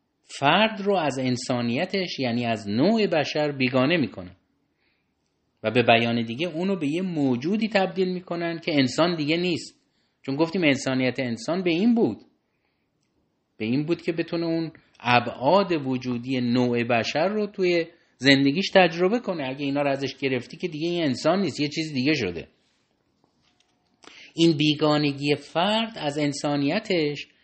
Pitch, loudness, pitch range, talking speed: 150 Hz, -24 LUFS, 130-175 Hz, 140 wpm